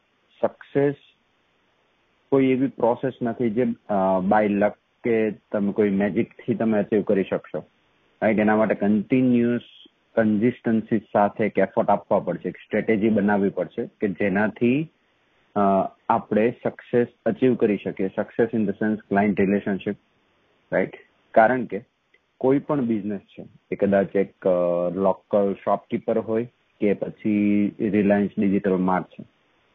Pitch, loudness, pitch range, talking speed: 105 Hz, -23 LUFS, 100-120 Hz, 125 wpm